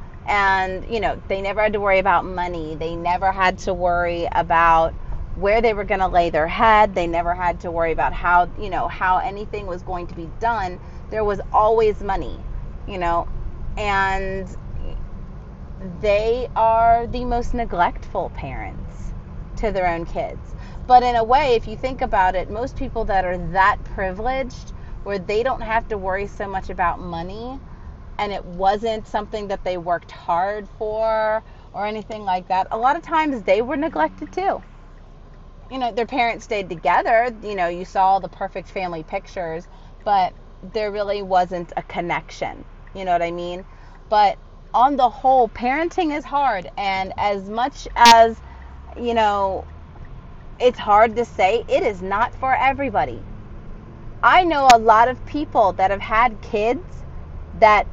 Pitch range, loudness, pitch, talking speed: 180-235 Hz, -20 LUFS, 205 Hz, 165 wpm